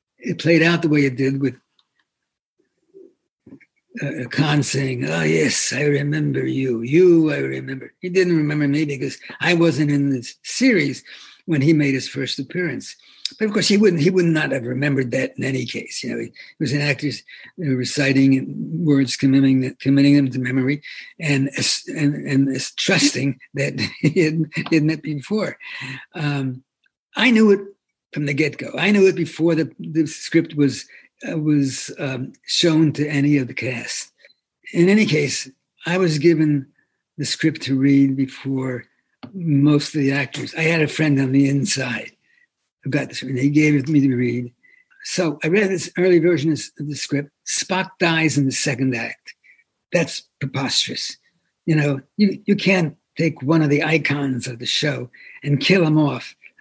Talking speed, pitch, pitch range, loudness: 175 wpm, 145 Hz, 135-165 Hz, -19 LUFS